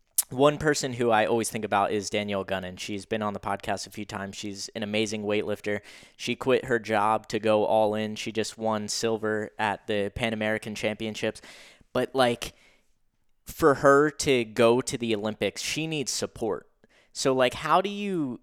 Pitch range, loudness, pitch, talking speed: 105-125 Hz, -27 LUFS, 110 Hz, 180 wpm